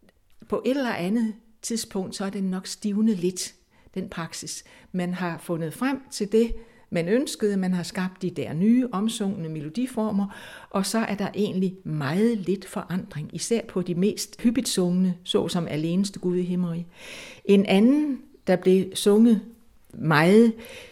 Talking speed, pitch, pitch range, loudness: 155 wpm, 200 Hz, 180-225 Hz, -25 LUFS